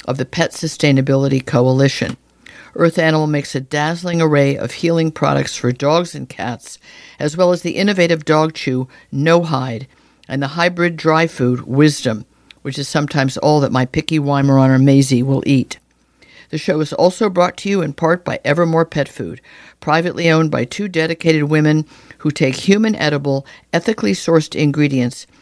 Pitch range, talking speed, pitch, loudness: 135-165 Hz, 165 wpm, 150 Hz, -16 LUFS